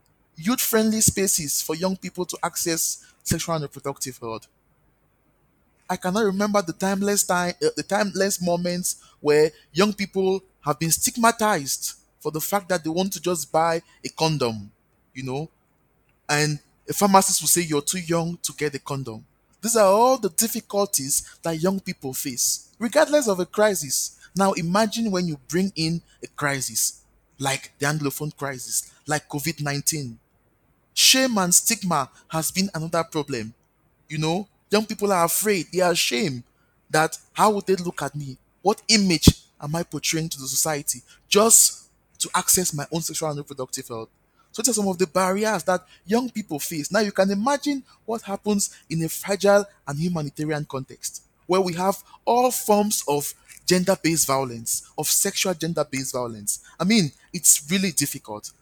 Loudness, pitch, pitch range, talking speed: -22 LUFS, 165 Hz, 145-195 Hz, 165 wpm